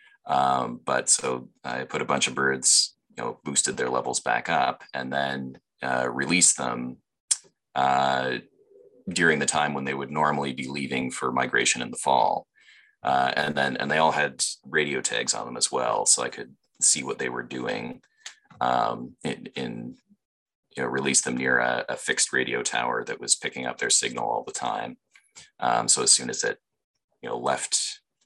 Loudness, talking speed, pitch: -24 LUFS, 185 wpm, 70 Hz